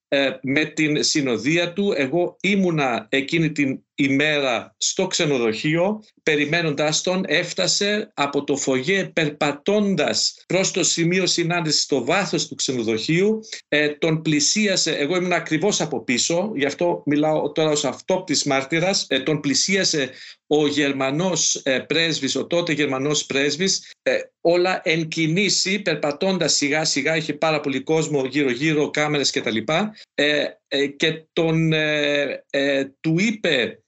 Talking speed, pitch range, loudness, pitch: 135 wpm, 145-175 Hz, -20 LUFS, 155 Hz